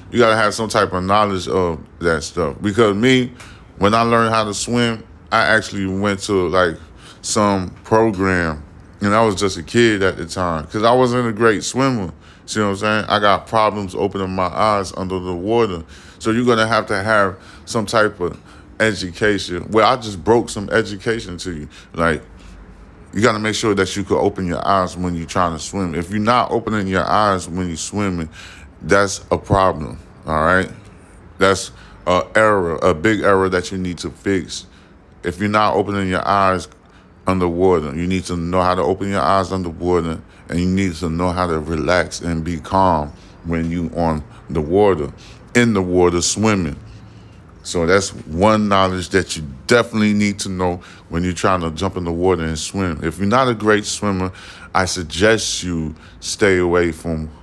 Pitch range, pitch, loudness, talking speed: 85-105 Hz, 95 Hz, -18 LUFS, 190 wpm